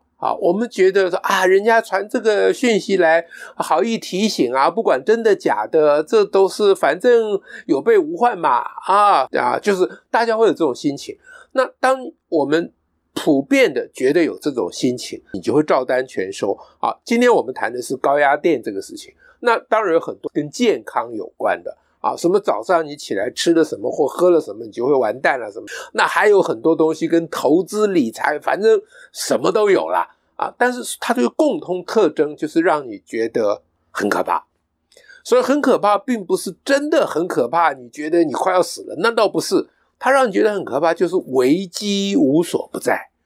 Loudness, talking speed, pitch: -18 LUFS, 280 characters per minute, 245 Hz